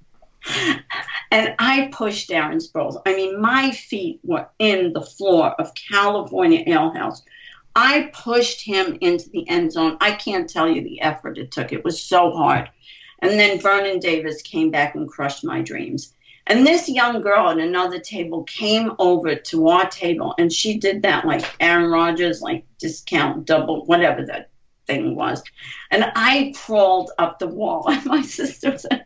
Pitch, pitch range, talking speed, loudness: 210 Hz, 175-280 Hz, 170 wpm, -19 LUFS